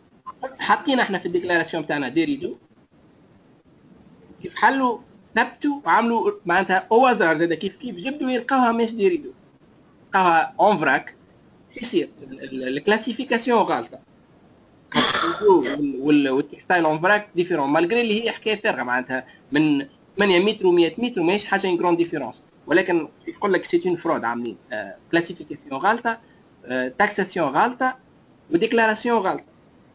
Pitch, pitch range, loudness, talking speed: 210 Hz, 170-245 Hz, -21 LUFS, 120 wpm